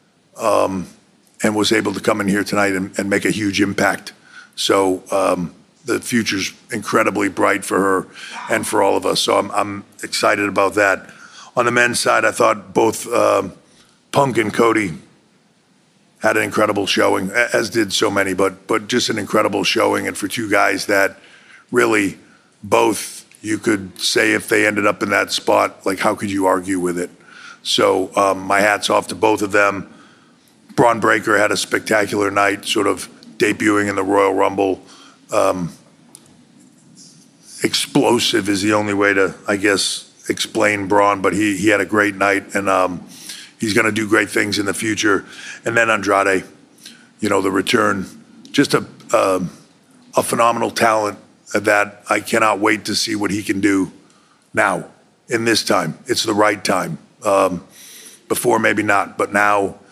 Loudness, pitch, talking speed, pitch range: -17 LUFS, 100 Hz, 170 wpm, 95-105 Hz